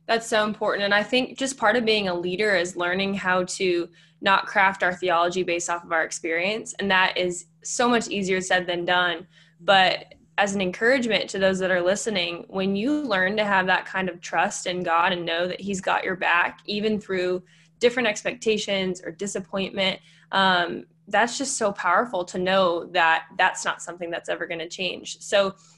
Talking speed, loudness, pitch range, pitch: 195 wpm, -23 LUFS, 175-205 Hz, 185 Hz